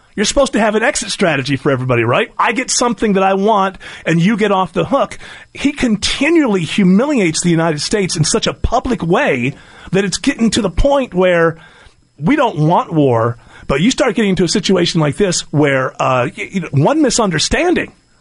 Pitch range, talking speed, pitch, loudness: 165-225 Hz, 190 wpm, 190 Hz, -14 LUFS